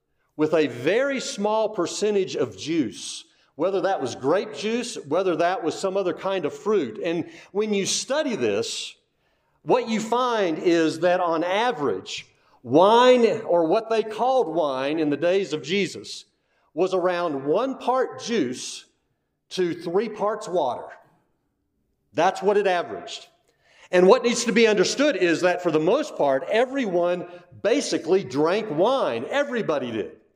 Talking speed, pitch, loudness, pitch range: 145 wpm, 195 Hz, -23 LUFS, 175-240 Hz